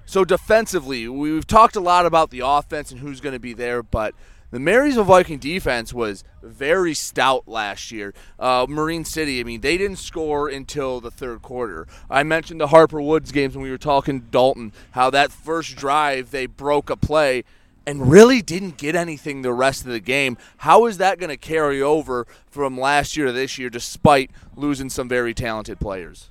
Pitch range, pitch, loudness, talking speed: 125-155 Hz, 140 Hz, -19 LUFS, 195 wpm